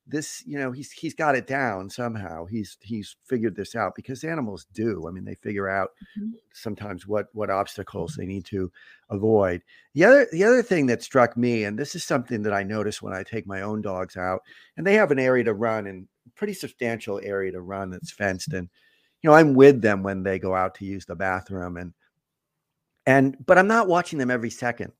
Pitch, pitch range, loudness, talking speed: 110 Hz, 95-135 Hz, -23 LUFS, 215 wpm